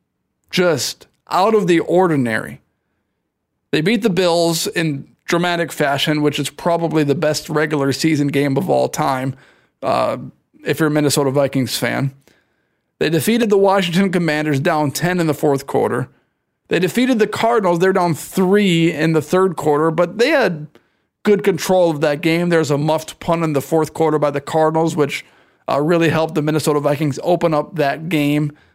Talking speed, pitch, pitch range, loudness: 170 wpm, 155 Hz, 145-175 Hz, -17 LUFS